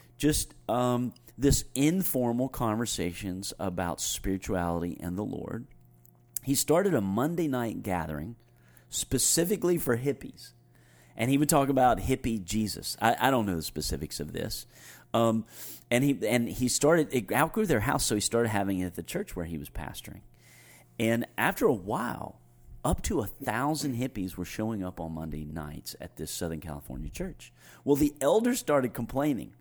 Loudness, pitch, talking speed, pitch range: -29 LUFS, 115 Hz, 165 wpm, 85-135 Hz